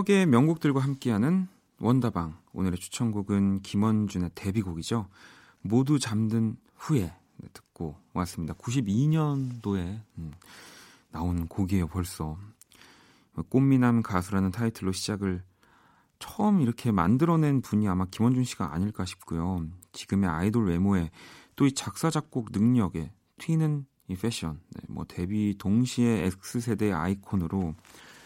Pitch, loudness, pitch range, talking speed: 105 Hz, -28 LUFS, 90-125 Hz, 270 characters per minute